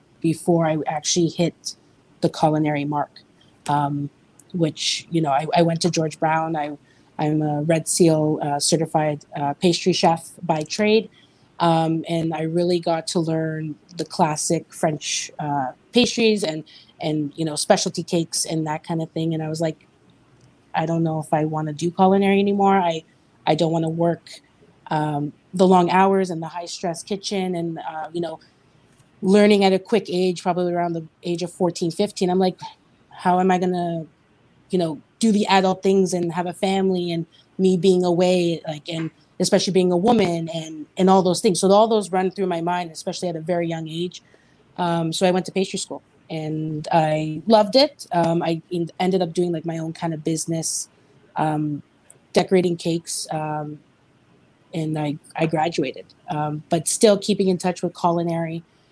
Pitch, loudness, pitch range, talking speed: 170 Hz, -21 LUFS, 155-185 Hz, 185 wpm